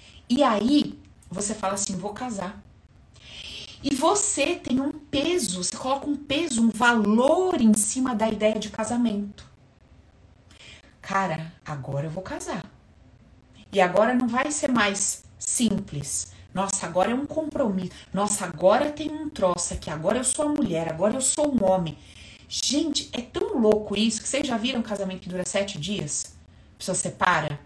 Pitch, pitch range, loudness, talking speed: 210 Hz, 180-265 Hz, -25 LUFS, 160 wpm